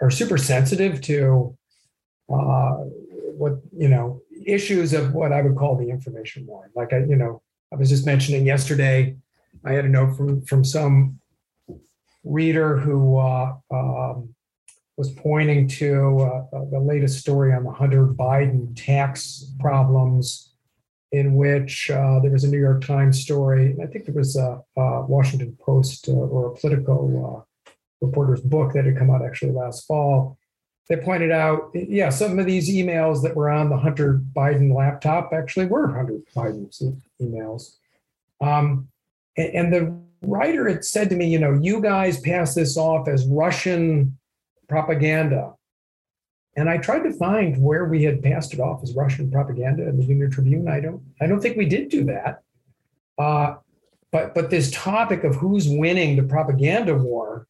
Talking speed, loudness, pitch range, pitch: 165 wpm, -21 LUFS, 130-155 Hz, 140 Hz